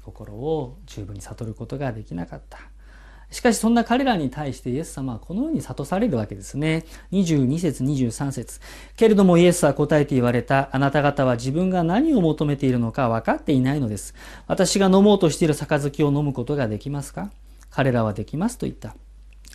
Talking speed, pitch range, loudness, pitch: 380 characters per minute, 125-170 Hz, -21 LUFS, 145 Hz